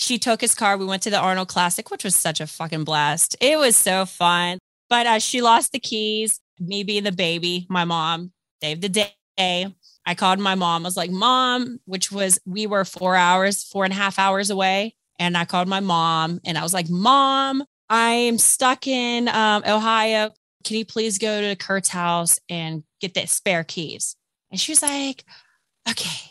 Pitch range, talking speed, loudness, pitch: 175-220 Hz, 200 wpm, -20 LUFS, 195 Hz